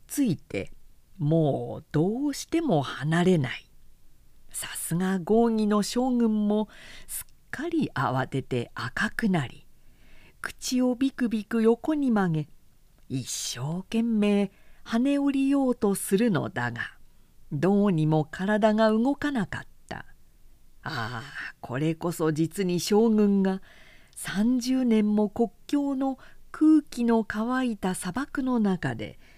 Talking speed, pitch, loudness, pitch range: 200 characters per minute, 210 Hz, -26 LUFS, 165-245 Hz